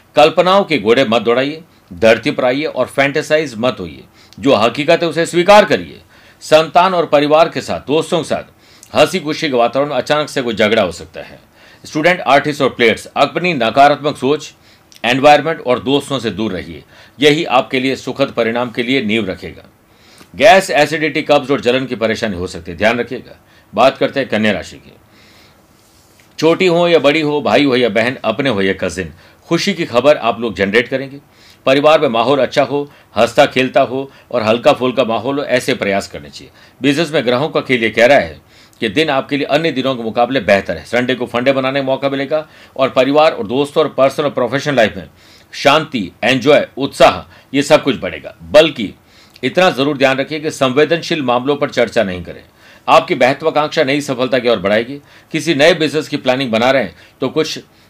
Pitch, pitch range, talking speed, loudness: 135 Hz, 115-150 Hz, 195 wpm, -14 LUFS